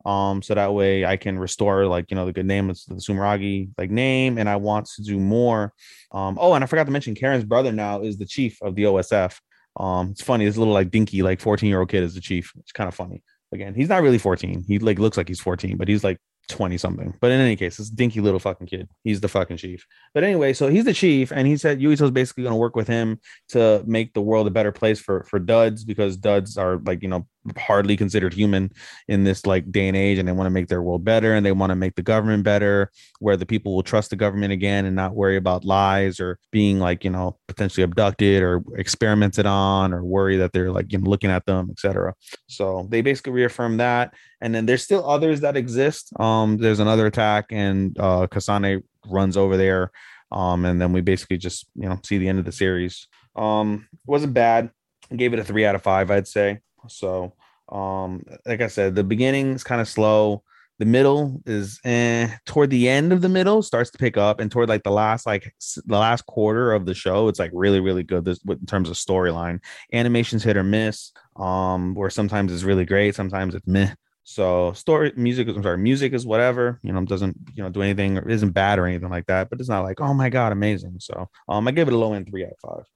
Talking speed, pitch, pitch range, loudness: 240 wpm, 100 Hz, 95-115 Hz, -21 LUFS